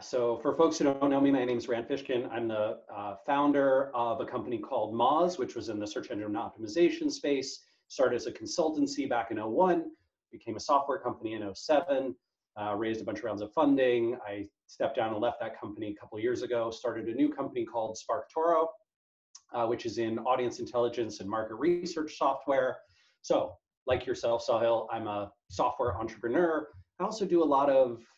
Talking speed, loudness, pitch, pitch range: 200 wpm, -31 LUFS, 130 Hz, 115-160 Hz